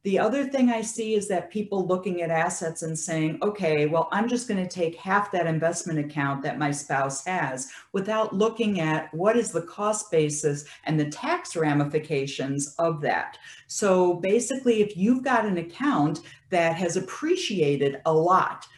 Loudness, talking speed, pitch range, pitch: -25 LUFS, 175 wpm, 155-215 Hz, 175 Hz